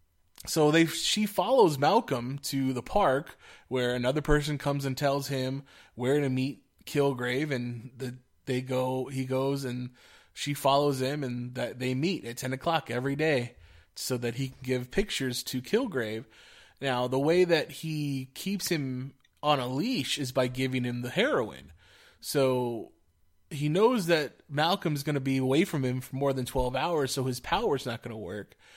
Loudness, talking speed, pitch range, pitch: -29 LUFS, 180 wpm, 125-145 Hz, 130 Hz